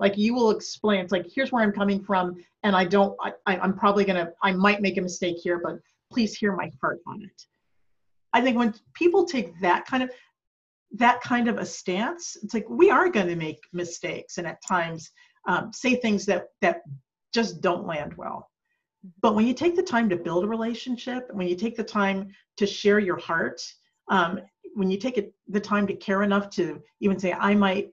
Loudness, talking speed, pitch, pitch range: -25 LUFS, 210 wpm, 205 Hz, 185-235 Hz